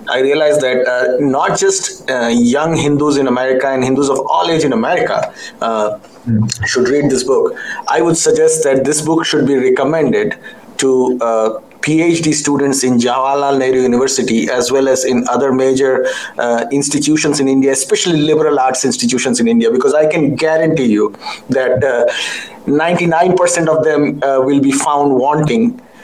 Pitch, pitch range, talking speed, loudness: 140 Hz, 130-160 Hz, 165 wpm, -13 LUFS